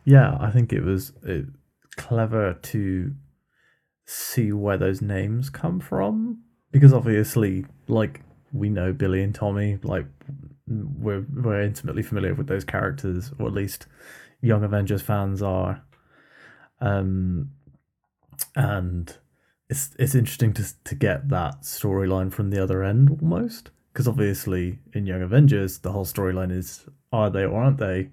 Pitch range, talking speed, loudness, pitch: 95-130 Hz, 140 wpm, -24 LUFS, 105 Hz